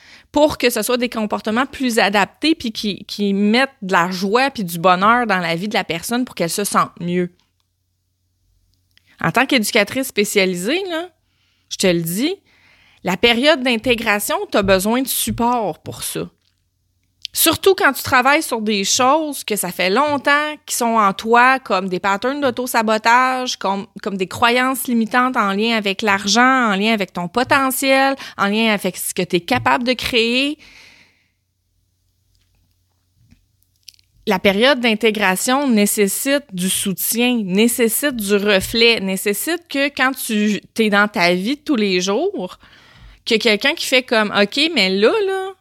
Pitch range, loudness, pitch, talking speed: 185-255 Hz, -17 LUFS, 220 Hz, 160 wpm